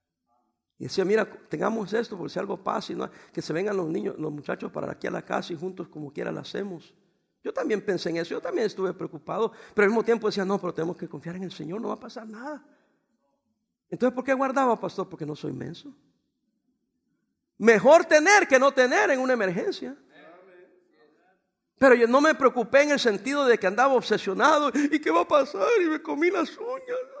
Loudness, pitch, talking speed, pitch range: -24 LUFS, 225 Hz, 205 wpm, 185-275 Hz